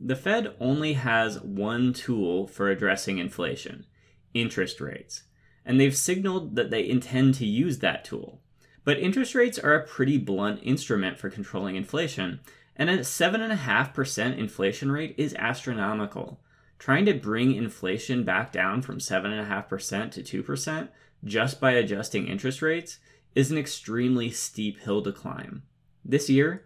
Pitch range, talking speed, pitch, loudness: 105-145 Hz, 140 wpm, 130 Hz, -27 LUFS